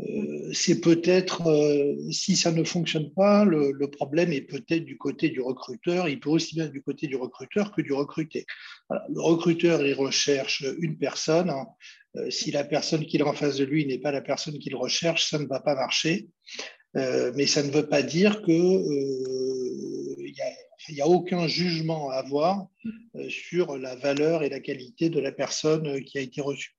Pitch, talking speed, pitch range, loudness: 150 Hz, 195 wpm, 140-170 Hz, -26 LUFS